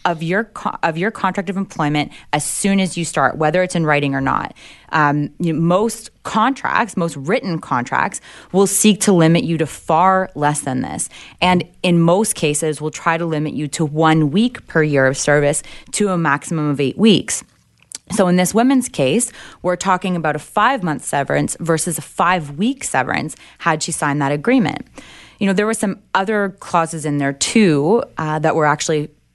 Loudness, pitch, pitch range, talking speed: -17 LUFS, 165 Hz, 150-195 Hz, 195 wpm